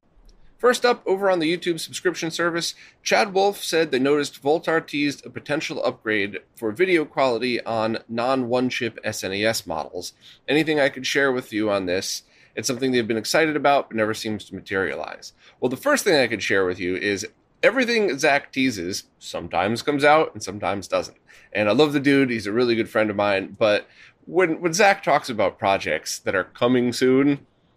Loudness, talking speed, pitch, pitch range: -22 LUFS, 190 wpm, 130 Hz, 110-160 Hz